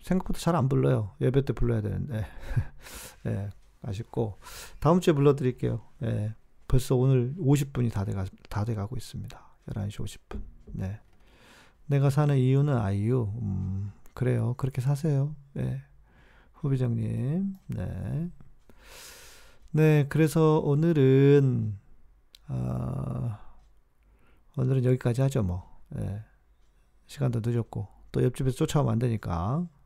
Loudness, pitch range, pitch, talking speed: -27 LUFS, 100-140 Hz, 125 Hz, 235 characters per minute